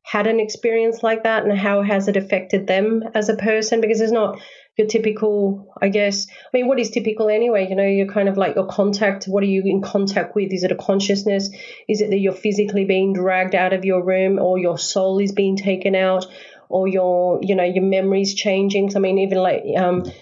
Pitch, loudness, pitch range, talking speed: 195 Hz, -19 LUFS, 190-210 Hz, 225 wpm